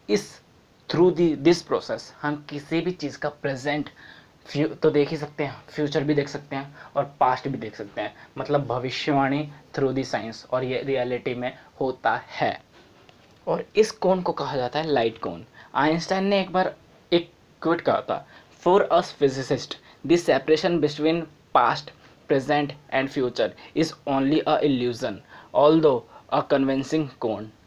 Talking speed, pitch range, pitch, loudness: 160 wpm, 135-155 Hz, 145 Hz, -24 LUFS